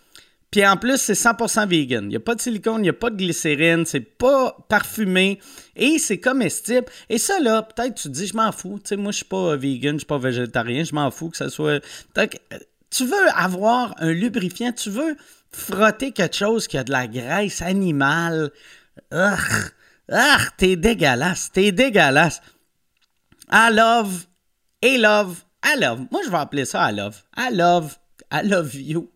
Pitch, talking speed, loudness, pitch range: 195 Hz, 195 wpm, -20 LUFS, 160-230 Hz